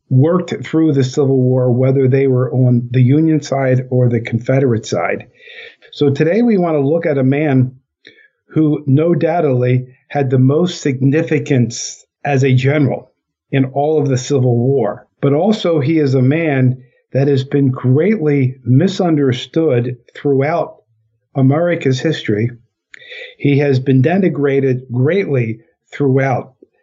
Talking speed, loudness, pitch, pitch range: 135 wpm, -15 LUFS, 135 Hz, 130-155 Hz